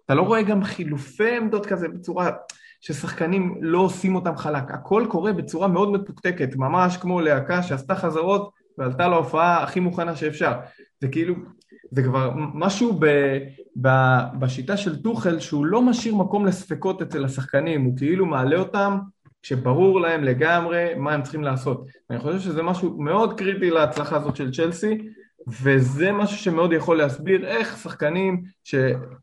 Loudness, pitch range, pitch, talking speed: -22 LUFS, 145-190 Hz, 170 Hz, 150 wpm